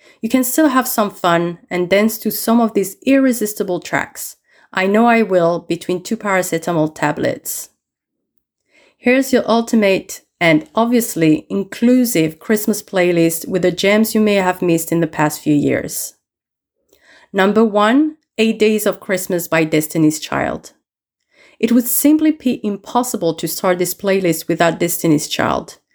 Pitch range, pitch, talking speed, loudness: 170-230 Hz, 195 Hz, 145 wpm, -16 LUFS